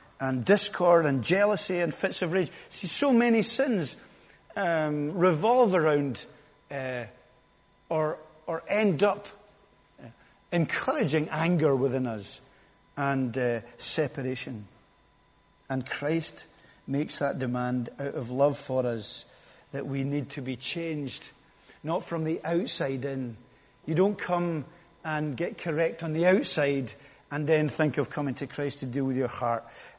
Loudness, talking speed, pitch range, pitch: -28 LUFS, 140 wpm, 130-170 Hz, 150 Hz